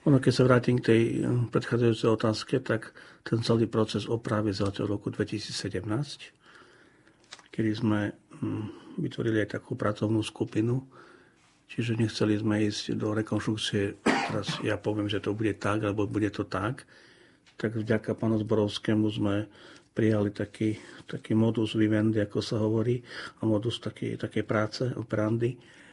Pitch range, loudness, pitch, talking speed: 105-115 Hz, -29 LUFS, 110 Hz, 135 wpm